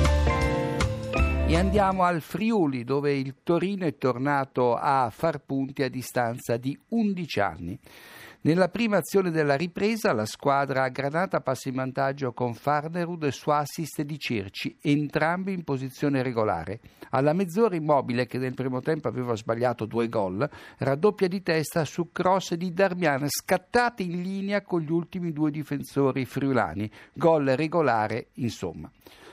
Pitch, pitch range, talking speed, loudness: 145 Hz, 125-175 Hz, 145 wpm, -26 LUFS